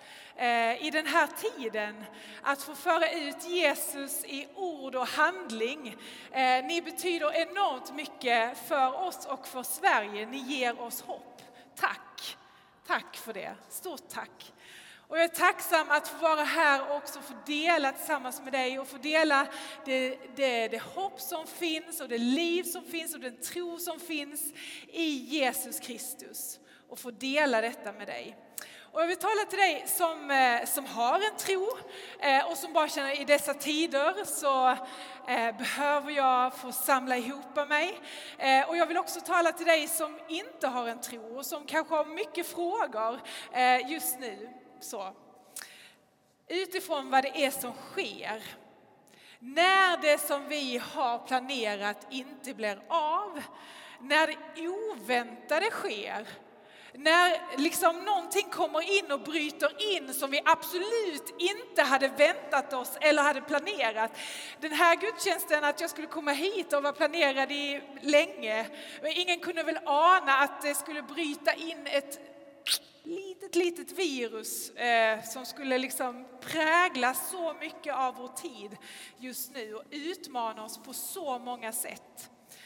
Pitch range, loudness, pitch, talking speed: 255-330 Hz, -29 LUFS, 290 Hz, 150 wpm